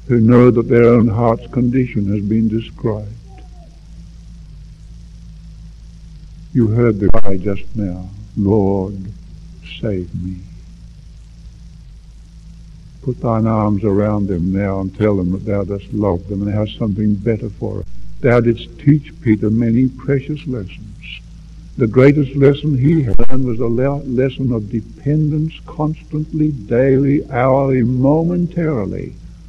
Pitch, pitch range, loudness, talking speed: 115 Hz, 105-135 Hz, -16 LUFS, 125 wpm